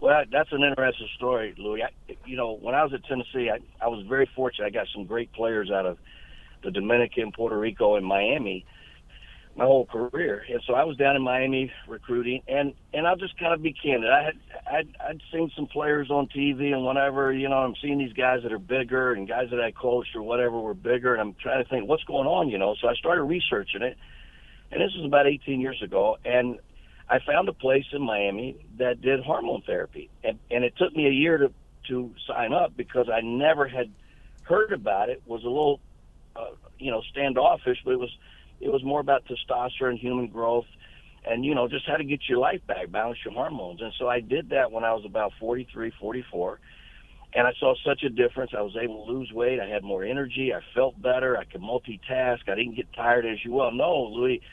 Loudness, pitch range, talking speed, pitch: -26 LUFS, 115-140 Hz, 225 wpm, 125 Hz